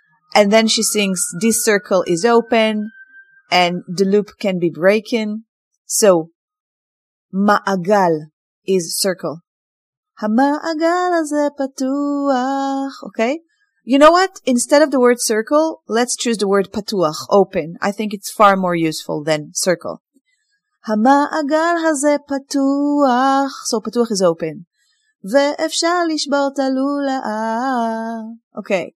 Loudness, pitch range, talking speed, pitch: -17 LUFS, 200-285 Hz, 105 wpm, 230 Hz